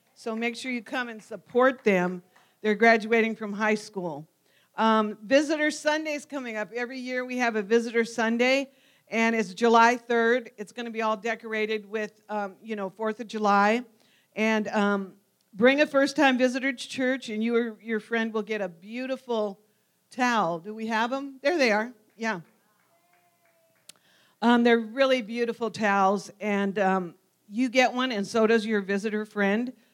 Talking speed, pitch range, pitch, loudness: 170 wpm, 210-245 Hz, 225 Hz, -26 LUFS